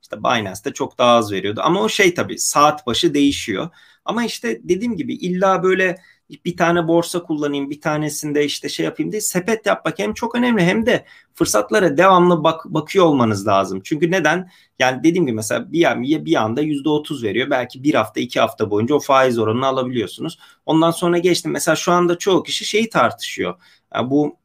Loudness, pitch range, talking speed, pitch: -18 LUFS, 140-185 Hz, 190 wpm, 165 Hz